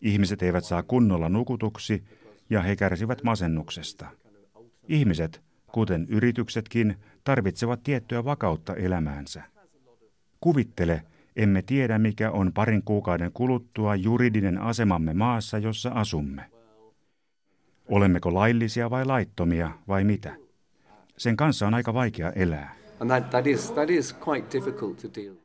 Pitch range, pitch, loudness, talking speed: 90-120 Hz, 105 Hz, -26 LUFS, 95 wpm